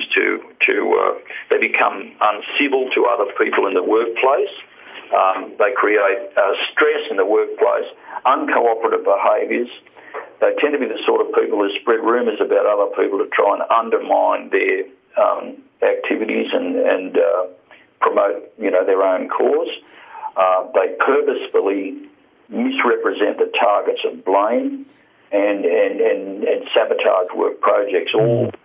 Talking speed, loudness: 140 wpm, -18 LUFS